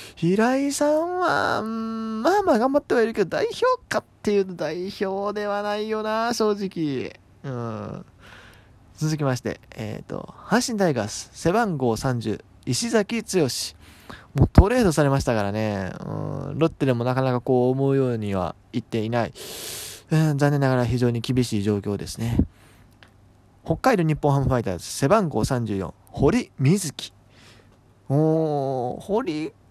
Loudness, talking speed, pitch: -23 LUFS, 280 characters per minute, 135 Hz